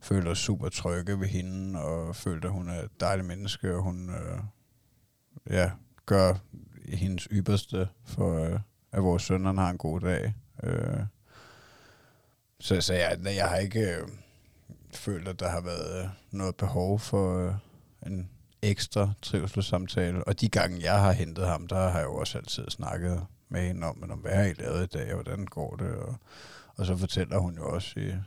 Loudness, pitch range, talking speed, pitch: -30 LUFS, 90-105 Hz, 185 wpm, 95 Hz